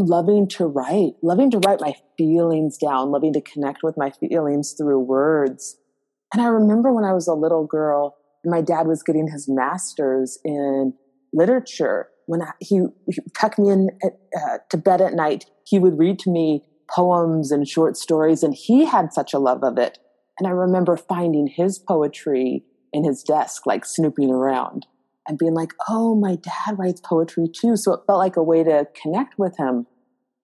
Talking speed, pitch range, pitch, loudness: 185 wpm, 145-190 Hz, 165 Hz, -20 LUFS